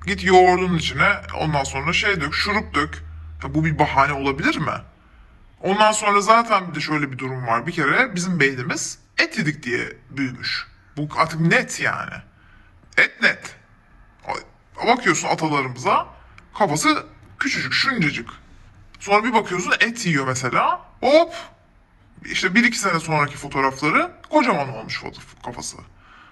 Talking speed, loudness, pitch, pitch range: 135 wpm, -20 LUFS, 165 Hz, 140-210 Hz